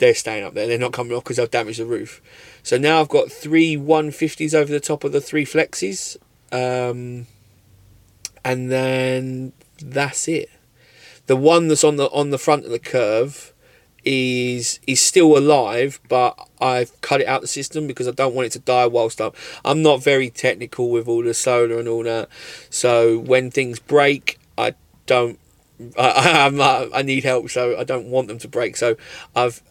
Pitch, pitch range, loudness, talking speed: 130 Hz, 120-145 Hz, -19 LUFS, 190 wpm